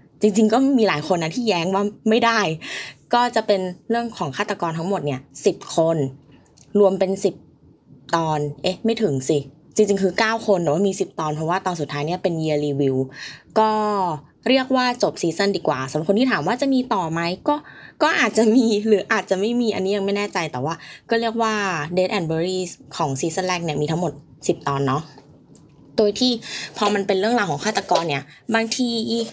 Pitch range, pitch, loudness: 155-220 Hz, 190 Hz, -21 LUFS